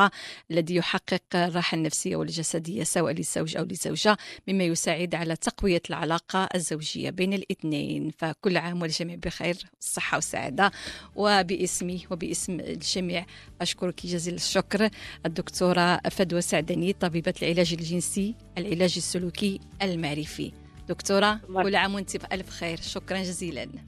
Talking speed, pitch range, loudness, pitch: 115 wpm, 170-190 Hz, -27 LUFS, 180 Hz